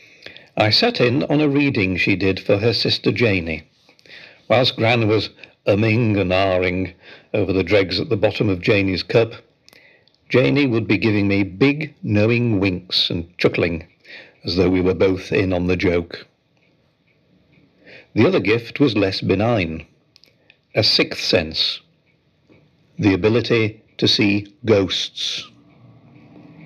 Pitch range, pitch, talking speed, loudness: 95-115 Hz, 105 Hz, 135 wpm, -18 LUFS